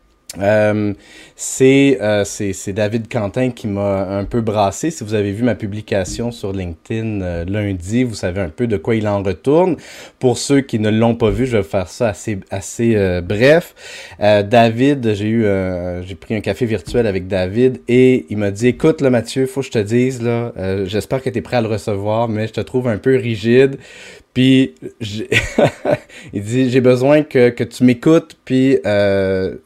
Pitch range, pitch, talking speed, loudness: 100-125 Hz, 110 Hz, 200 wpm, -16 LUFS